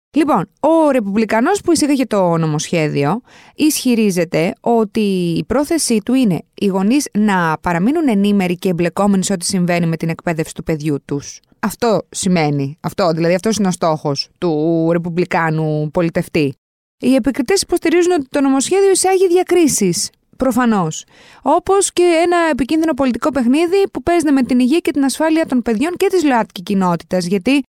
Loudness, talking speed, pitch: -15 LUFS, 150 wpm, 220 Hz